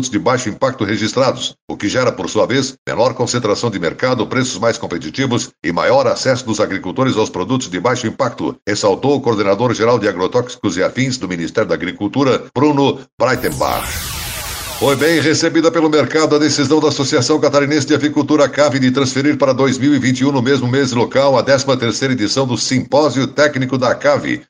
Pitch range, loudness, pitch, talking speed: 120-145 Hz, -15 LUFS, 130 Hz, 170 wpm